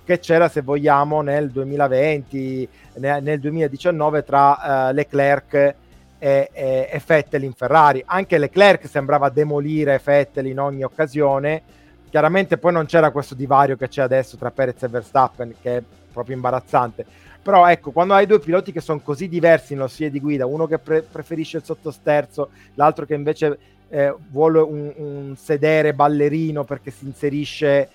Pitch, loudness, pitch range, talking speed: 145 Hz, -18 LUFS, 135-155 Hz, 155 wpm